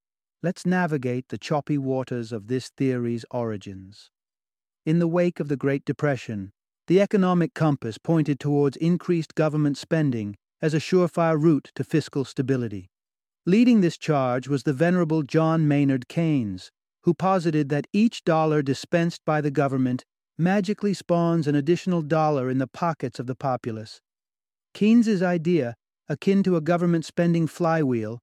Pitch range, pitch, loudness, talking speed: 130-170 Hz, 150 Hz, -24 LUFS, 145 wpm